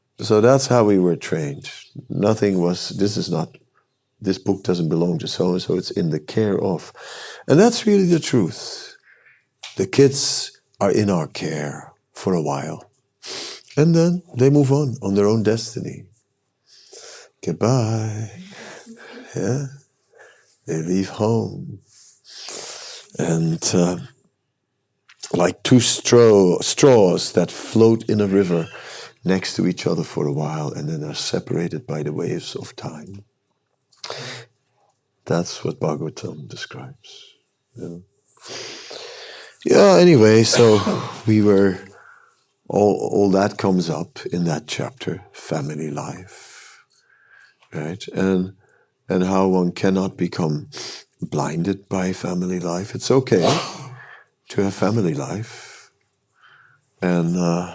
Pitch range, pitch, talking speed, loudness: 95-135 Hz, 105 Hz, 120 wpm, -19 LUFS